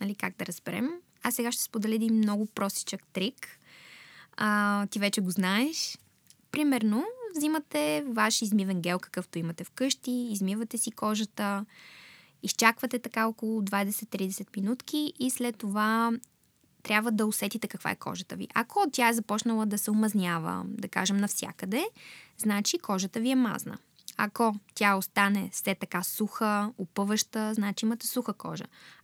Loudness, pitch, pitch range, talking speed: -29 LUFS, 215 Hz, 200-235 Hz, 145 wpm